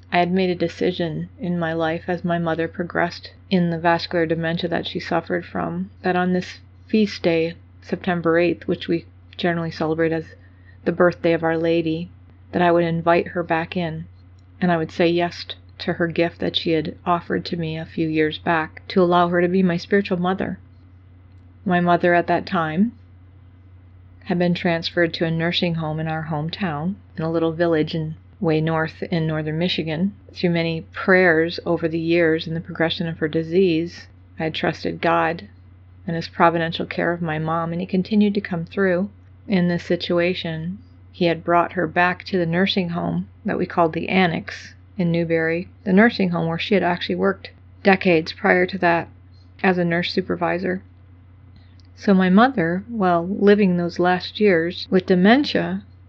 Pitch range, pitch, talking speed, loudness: 155-180 Hz, 170 Hz, 180 wpm, -21 LUFS